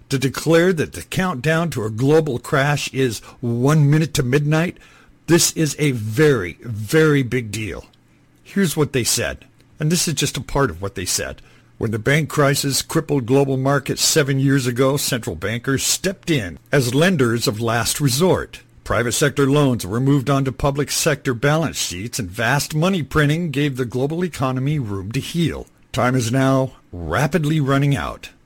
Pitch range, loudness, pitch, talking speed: 120-150 Hz, -19 LUFS, 140 Hz, 170 wpm